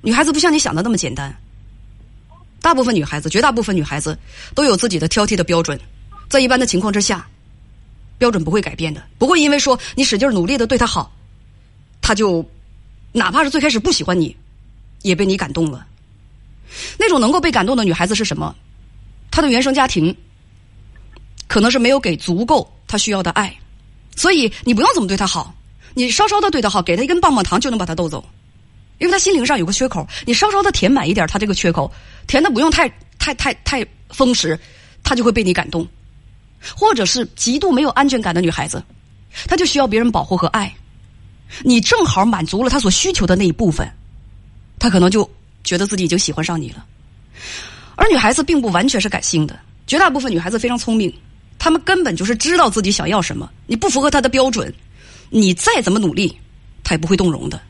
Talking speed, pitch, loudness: 310 characters per minute, 190 Hz, -16 LUFS